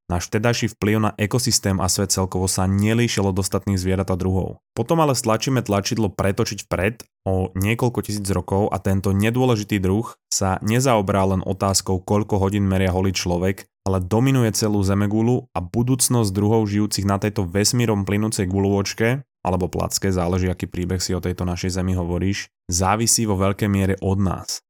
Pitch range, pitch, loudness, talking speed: 95-110 Hz, 100 Hz, -21 LUFS, 165 wpm